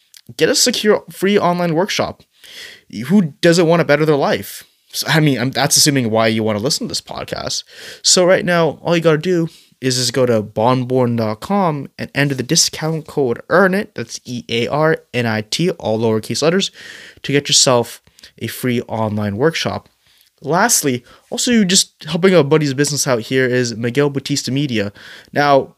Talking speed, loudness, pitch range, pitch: 180 wpm, -16 LUFS, 120-170 Hz, 140 Hz